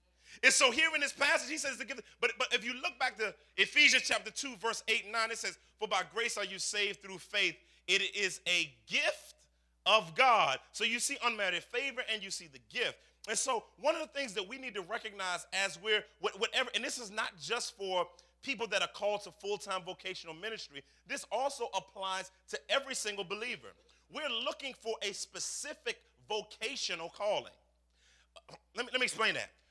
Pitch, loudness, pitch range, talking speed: 220 Hz, -33 LUFS, 190-260 Hz, 200 wpm